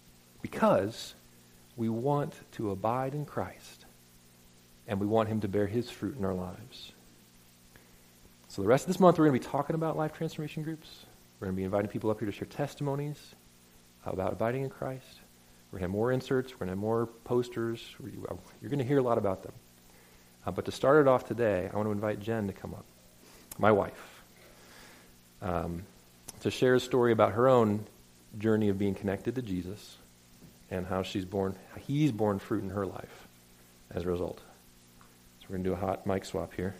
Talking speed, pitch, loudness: 200 wpm, 95 Hz, -31 LUFS